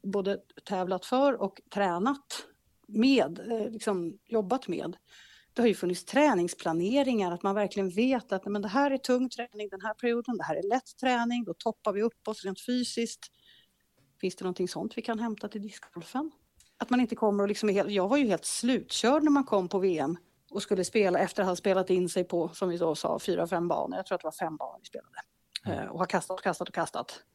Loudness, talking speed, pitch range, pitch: -30 LUFS, 210 wpm, 185-240 Hz, 210 Hz